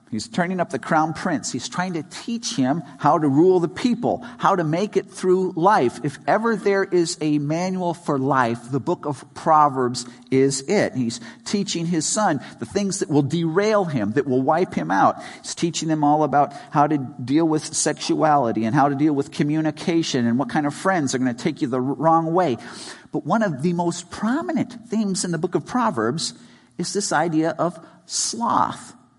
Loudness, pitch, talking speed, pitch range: -21 LUFS, 160 Hz, 200 wpm, 145-185 Hz